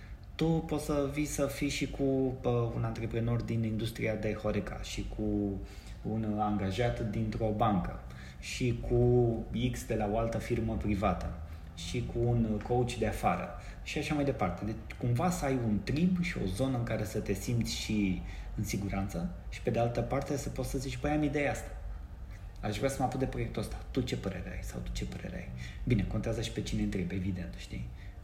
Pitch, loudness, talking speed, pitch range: 110 Hz, -33 LUFS, 200 wpm, 100-125 Hz